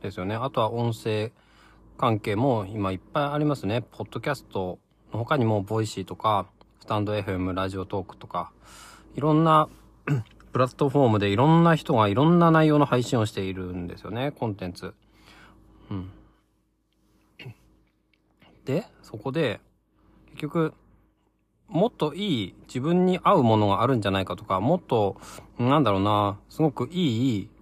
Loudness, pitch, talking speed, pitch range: -25 LUFS, 110 Hz, 305 characters per minute, 100-145 Hz